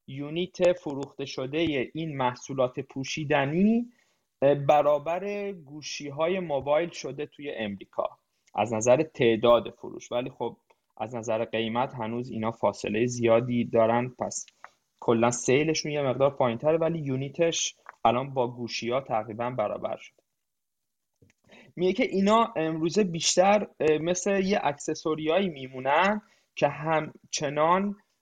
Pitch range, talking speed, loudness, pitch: 120-165 Hz, 115 wpm, -27 LUFS, 145 Hz